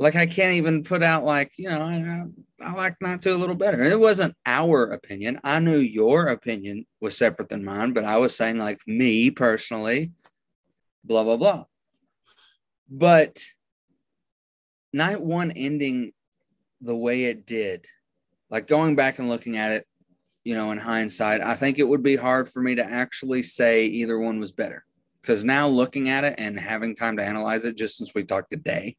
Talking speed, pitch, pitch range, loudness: 185 wpm, 125 Hz, 110-160 Hz, -23 LUFS